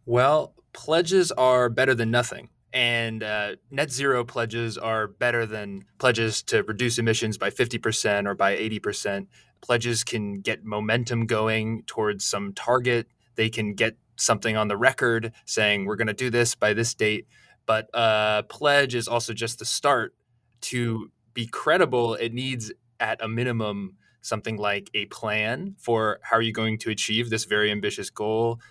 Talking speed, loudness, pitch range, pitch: 165 wpm, -24 LUFS, 110-120 Hz, 115 Hz